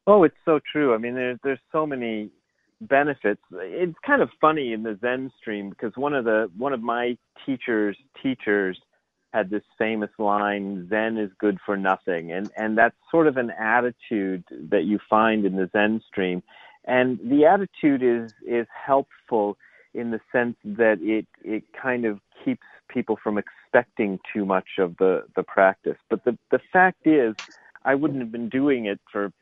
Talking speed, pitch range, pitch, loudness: 175 wpm, 105-135 Hz, 115 Hz, -24 LUFS